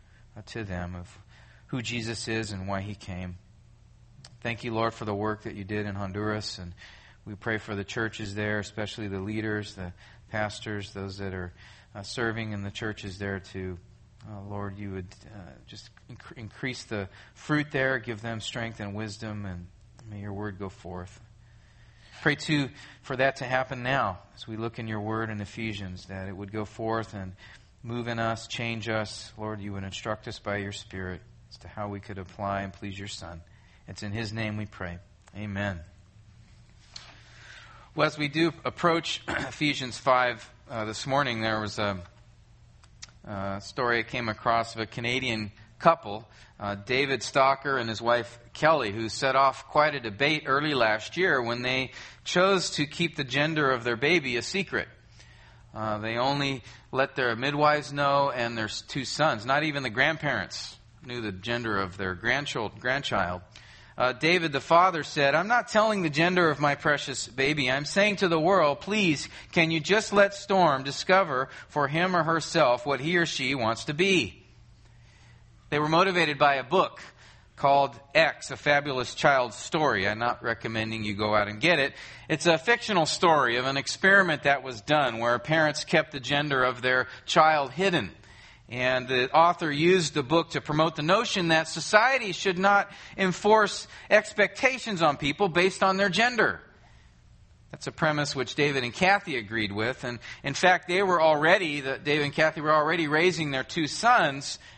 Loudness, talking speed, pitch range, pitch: -26 LUFS, 175 wpm, 105-145 Hz, 120 Hz